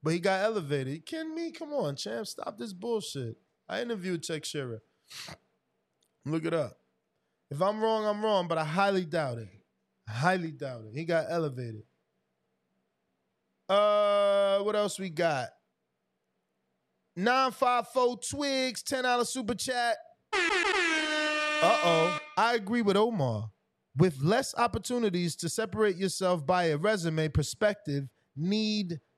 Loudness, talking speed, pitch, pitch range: -29 LUFS, 135 wpm, 195 Hz, 160-240 Hz